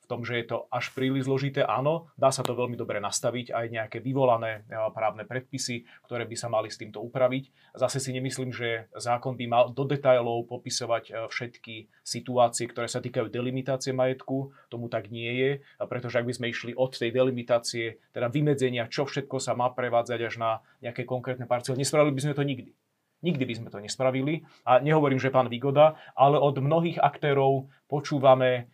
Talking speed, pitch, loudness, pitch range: 185 wpm, 125 Hz, -27 LUFS, 120-135 Hz